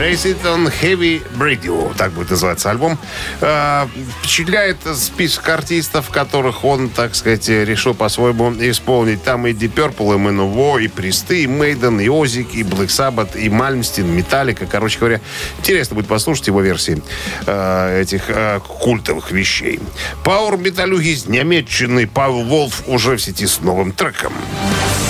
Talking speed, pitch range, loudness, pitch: 145 wpm, 100-140 Hz, -15 LUFS, 120 Hz